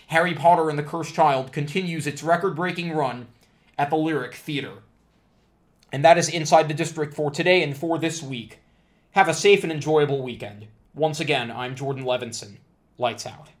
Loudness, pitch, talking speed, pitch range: -22 LUFS, 155 Hz, 175 wpm, 135-165 Hz